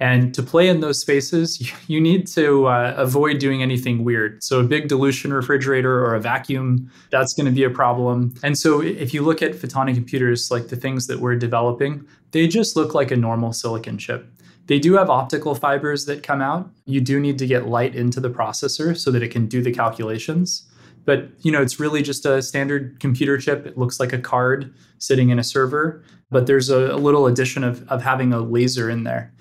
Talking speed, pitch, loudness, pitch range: 215 wpm, 135 Hz, -19 LUFS, 125-145 Hz